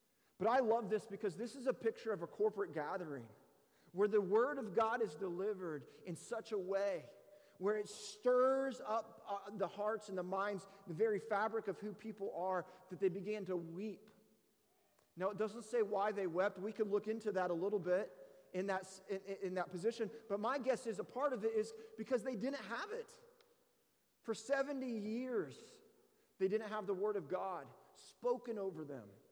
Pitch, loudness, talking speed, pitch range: 210 Hz, -40 LUFS, 190 wpm, 190-230 Hz